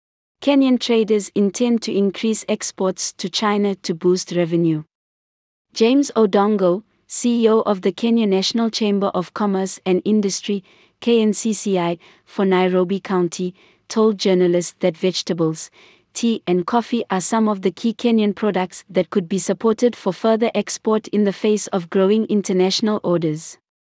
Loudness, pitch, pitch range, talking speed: -19 LUFS, 200 Hz, 185-220 Hz, 140 wpm